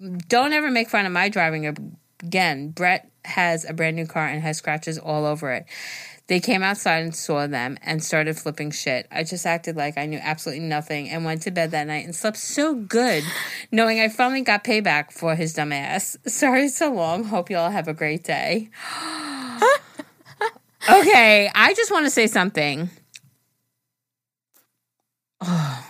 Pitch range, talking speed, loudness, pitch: 155-220 Hz, 175 wpm, -21 LUFS, 170 Hz